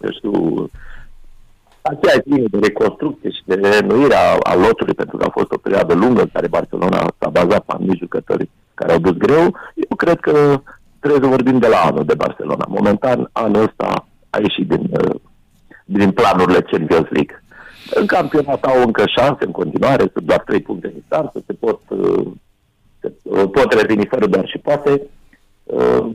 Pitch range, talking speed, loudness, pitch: 120-150 Hz, 170 wpm, -15 LUFS, 140 Hz